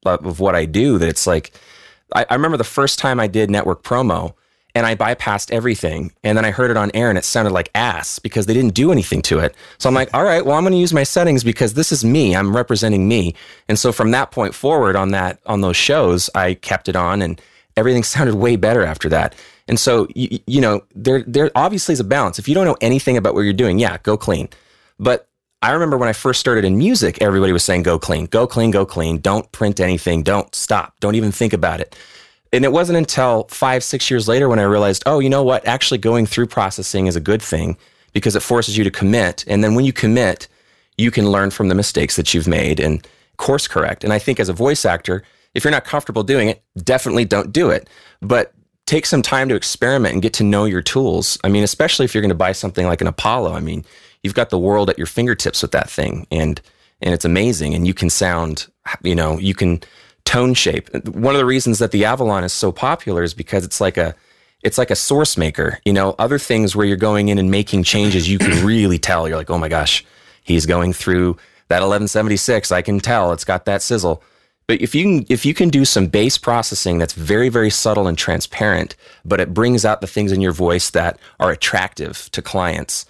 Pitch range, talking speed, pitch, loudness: 90-120 Hz, 235 wpm, 105 Hz, -16 LUFS